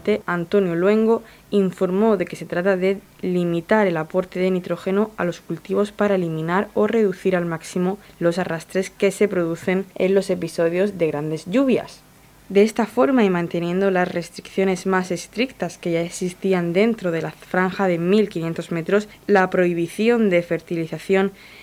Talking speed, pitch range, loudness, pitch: 155 wpm, 170-200 Hz, -21 LUFS, 185 Hz